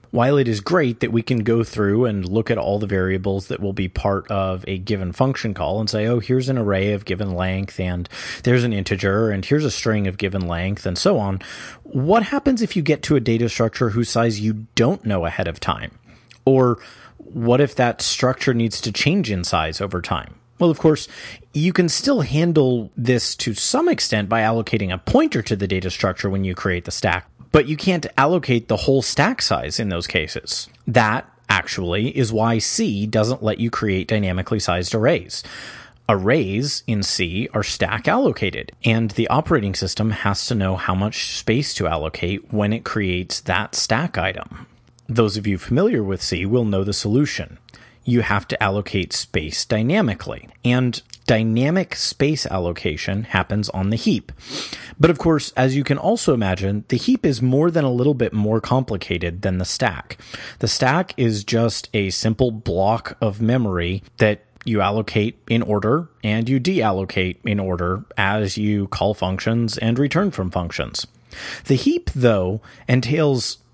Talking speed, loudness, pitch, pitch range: 180 wpm, -20 LUFS, 110 Hz, 95-125 Hz